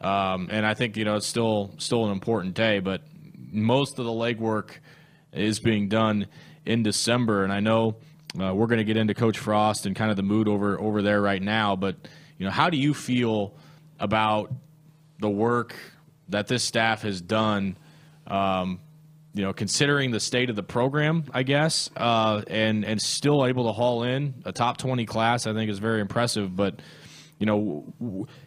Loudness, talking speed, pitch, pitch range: -25 LUFS, 190 wpm, 110 Hz, 105-135 Hz